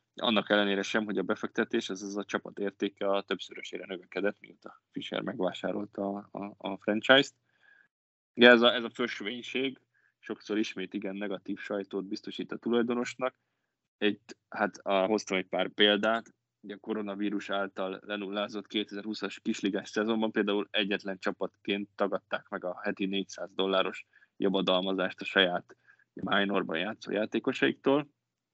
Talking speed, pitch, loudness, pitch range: 140 wpm, 100 Hz, -30 LUFS, 95-110 Hz